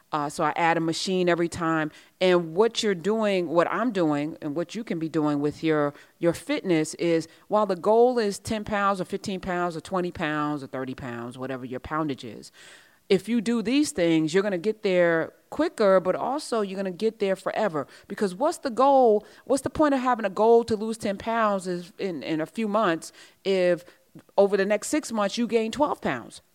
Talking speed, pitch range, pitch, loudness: 215 wpm, 165-225 Hz, 190 Hz, -25 LUFS